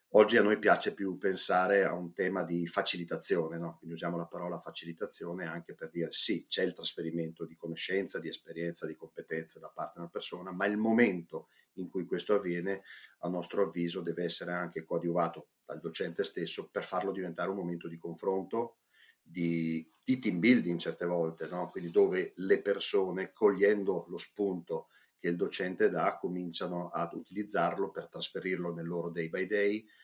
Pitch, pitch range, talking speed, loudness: 85 Hz, 85-100 Hz, 175 wpm, -33 LUFS